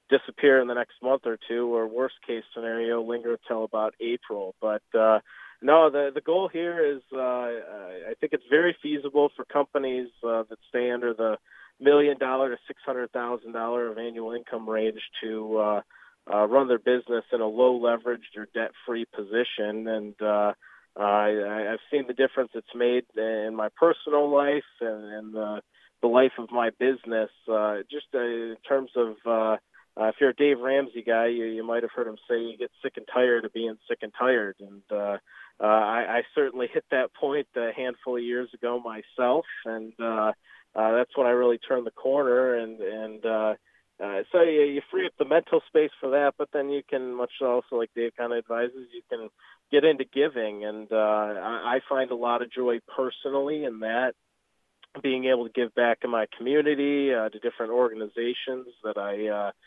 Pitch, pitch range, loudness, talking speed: 120 Hz, 110-135 Hz, -26 LUFS, 195 wpm